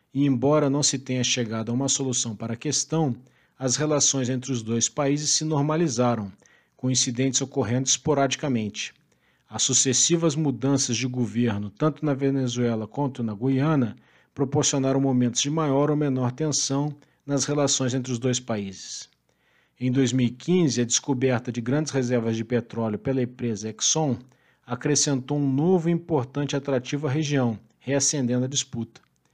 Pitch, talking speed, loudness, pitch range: 130 Hz, 145 wpm, -24 LUFS, 125-145 Hz